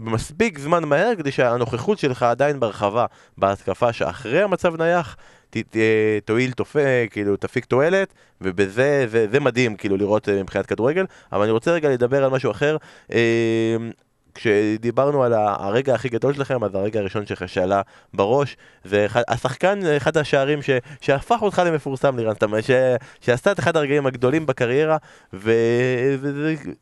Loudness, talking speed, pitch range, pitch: -20 LUFS, 145 wpm, 110-145 Hz, 125 Hz